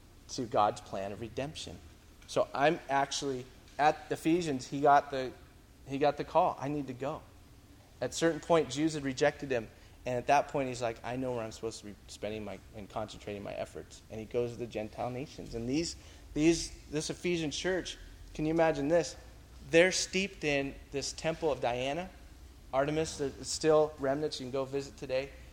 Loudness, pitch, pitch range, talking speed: -33 LUFS, 135 Hz, 105-150 Hz, 190 wpm